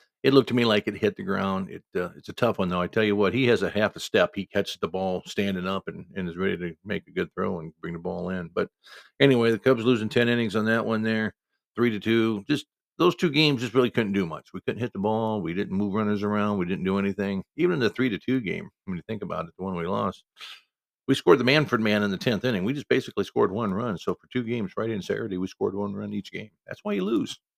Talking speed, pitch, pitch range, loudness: 285 wpm, 110 Hz, 100-125 Hz, -26 LUFS